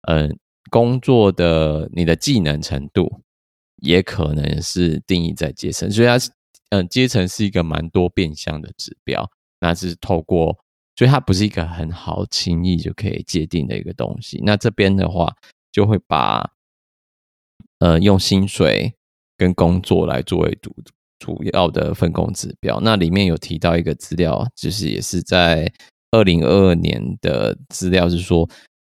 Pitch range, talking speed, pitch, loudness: 80-100 Hz, 235 characters per minute, 90 Hz, -18 LUFS